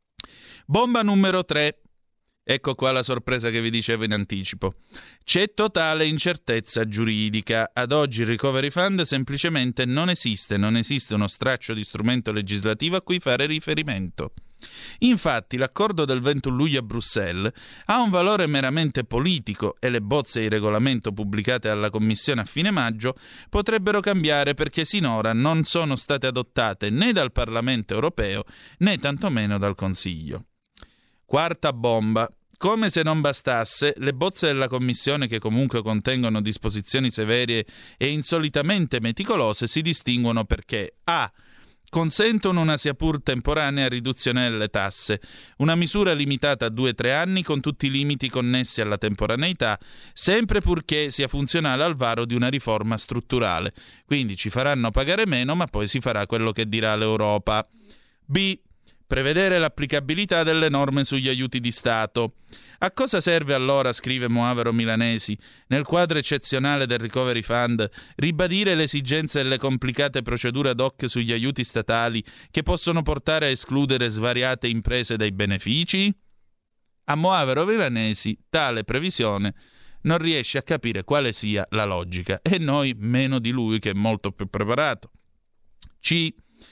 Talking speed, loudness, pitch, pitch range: 145 wpm, -23 LUFS, 130 Hz, 115-155 Hz